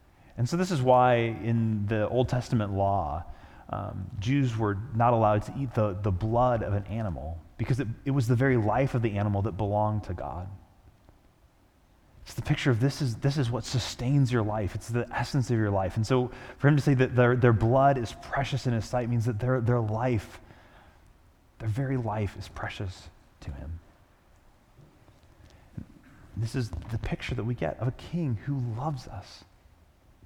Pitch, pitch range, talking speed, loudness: 110 Hz, 100-125 Hz, 190 wpm, -28 LUFS